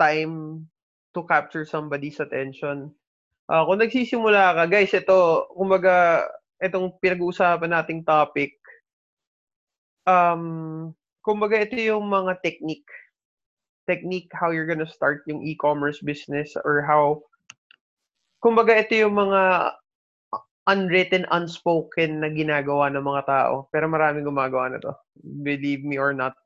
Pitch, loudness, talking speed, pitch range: 165 Hz, -22 LUFS, 120 wpm, 150-185 Hz